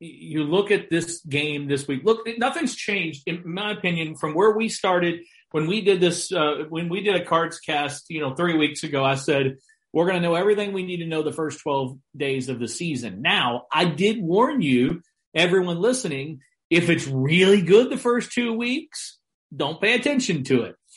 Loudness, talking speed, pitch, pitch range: -22 LUFS, 205 wpm, 170 Hz, 150-200 Hz